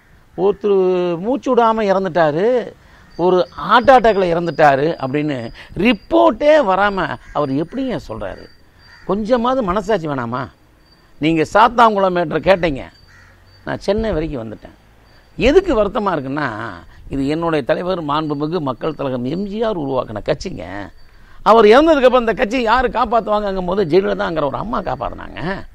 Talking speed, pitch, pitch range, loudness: 105 wpm, 180 Hz, 145-220 Hz, -16 LUFS